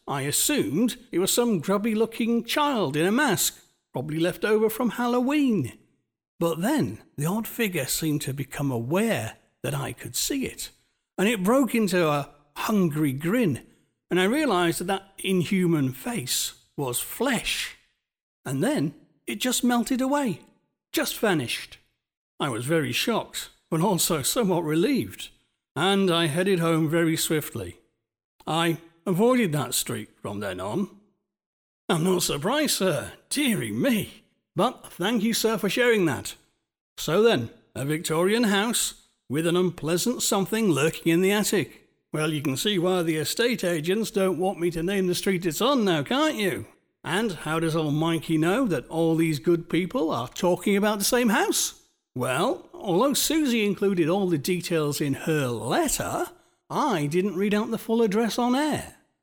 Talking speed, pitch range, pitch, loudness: 160 wpm, 160-225 Hz, 180 Hz, -25 LUFS